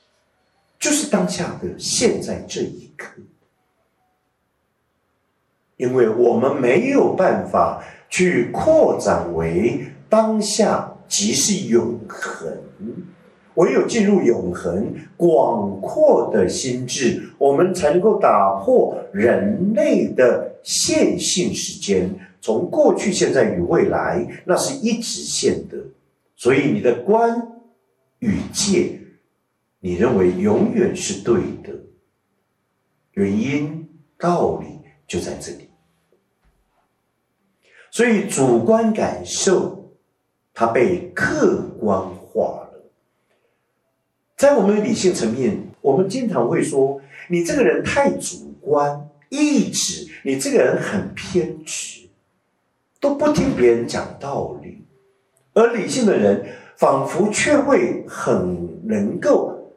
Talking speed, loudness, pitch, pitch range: 155 characters per minute, -19 LUFS, 190 Hz, 145-225 Hz